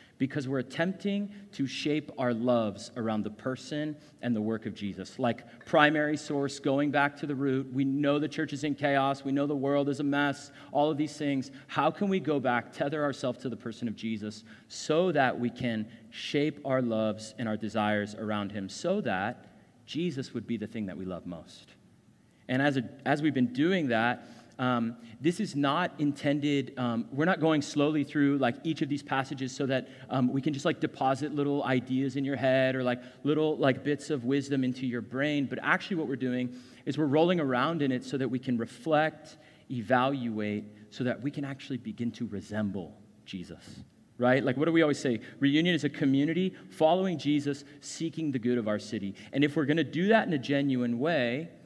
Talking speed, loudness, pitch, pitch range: 210 wpm, -30 LUFS, 135 Hz, 120-150 Hz